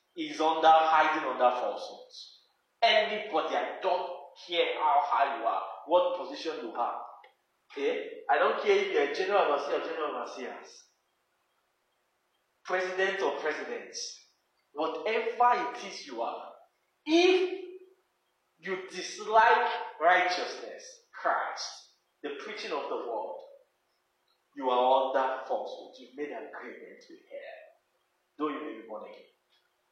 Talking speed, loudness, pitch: 125 wpm, -29 LUFS, 230 Hz